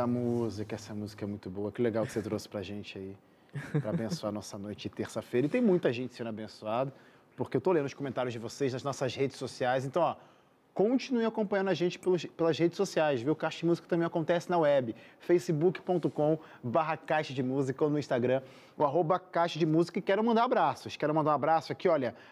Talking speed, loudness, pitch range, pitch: 210 wpm, -31 LUFS, 120-170 Hz, 145 Hz